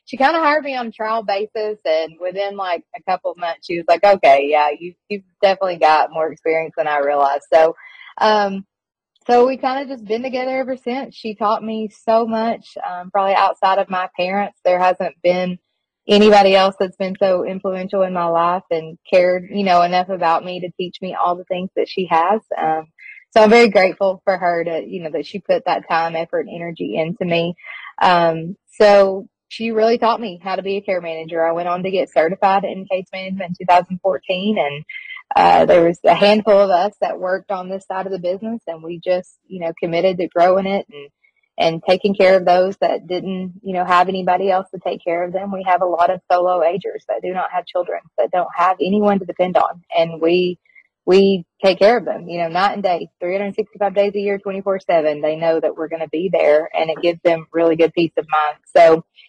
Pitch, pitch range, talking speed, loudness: 185 Hz, 170-205 Hz, 225 wpm, -17 LUFS